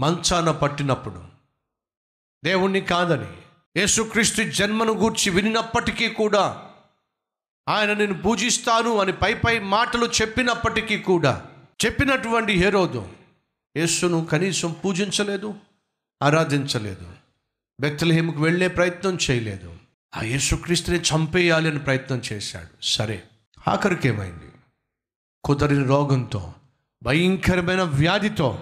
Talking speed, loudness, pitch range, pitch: 85 wpm, -21 LUFS, 135-205 Hz, 175 Hz